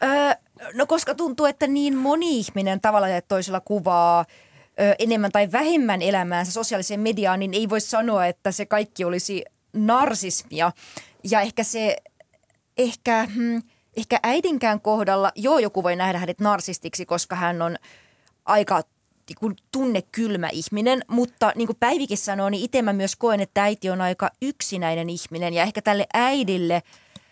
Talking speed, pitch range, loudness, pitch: 145 wpm, 185-235 Hz, -22 LUFS, 210 Hz